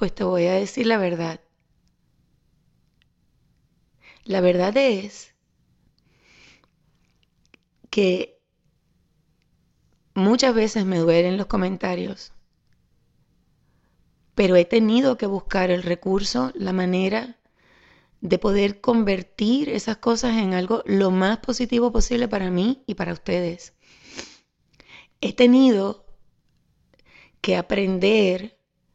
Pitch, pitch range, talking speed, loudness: 200 Hz, 185-230 Hz, 95 wpm, -21 LUFS